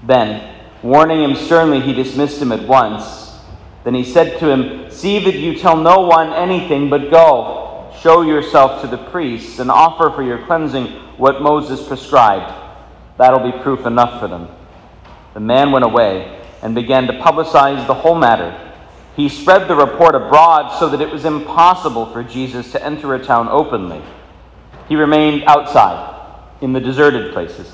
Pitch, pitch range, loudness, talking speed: 145 Hz, 125-160 Hz, -13 LUFS, 165 wpm